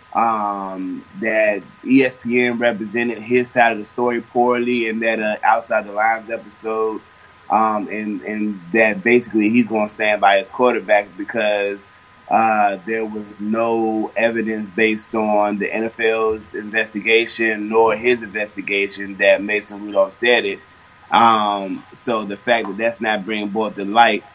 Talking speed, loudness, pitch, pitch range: 145 wpm, -18 LUFS, 110 Hz, 105-115 Hz